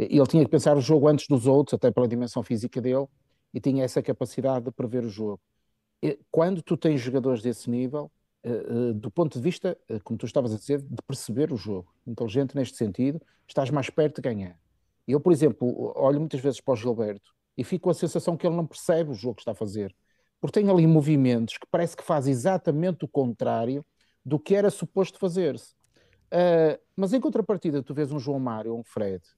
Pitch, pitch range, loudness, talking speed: 140 Hz, 120-160 Hz, -26 LUFS, 215 wpm